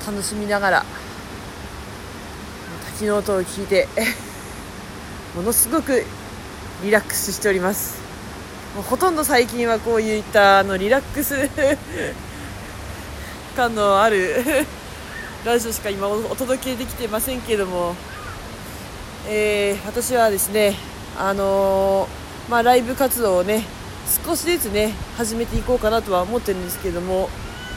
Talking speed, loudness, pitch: 260 characters per minute, -20 LUFS, 200 Hz